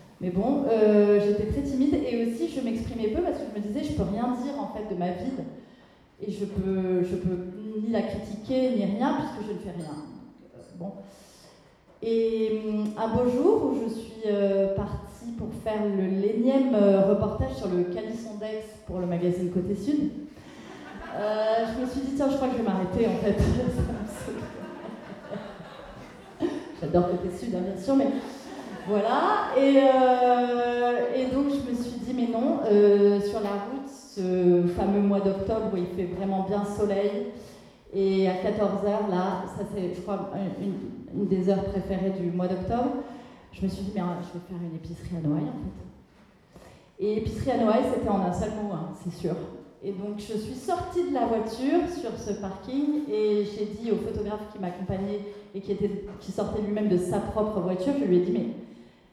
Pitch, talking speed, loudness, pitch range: 210 Hz, 190 wpm, -27 LUFS, 195-240 Hz